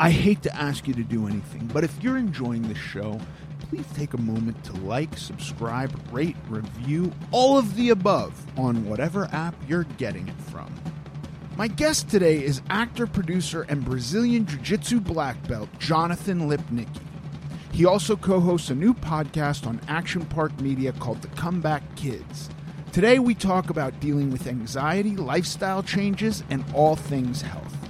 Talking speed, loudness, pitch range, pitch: 160 wpm, -25 LUFS, 135-180 Hz, 155 Hz